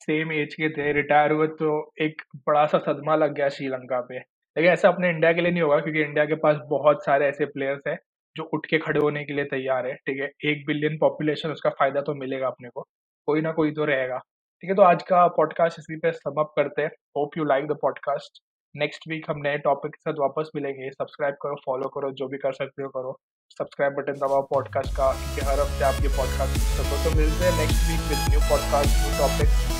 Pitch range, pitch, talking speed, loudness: 135-155 Hz, 150 Hz, 225 wpm, -24 LUFS